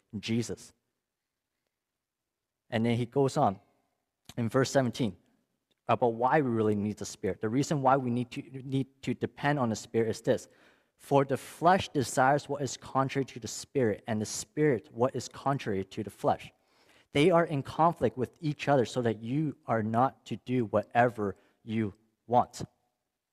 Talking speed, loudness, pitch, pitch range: 170 wpm, -30 LUFS, 125 Hz, 110-140 Hz